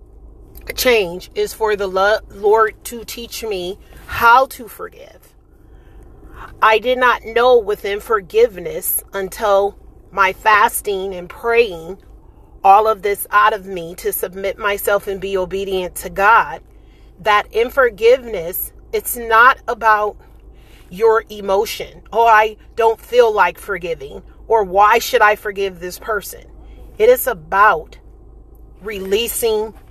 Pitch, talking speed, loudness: 220 Hz, 120 wpm, -16 LUFS